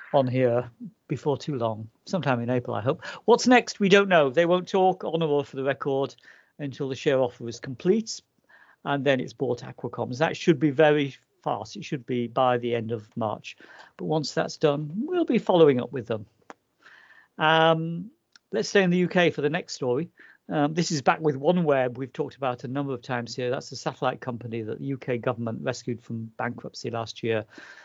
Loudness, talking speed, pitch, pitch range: -25 LUFS, 205 wpm, 140 Hz, 125-165 Hz